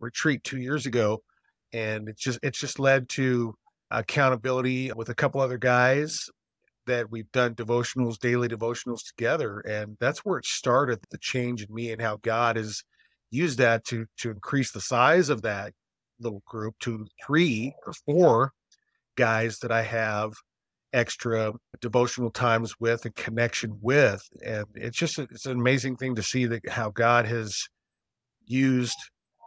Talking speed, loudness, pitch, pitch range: 160 wpm, -26 LUFS, 120 Hz, 115-130 Hz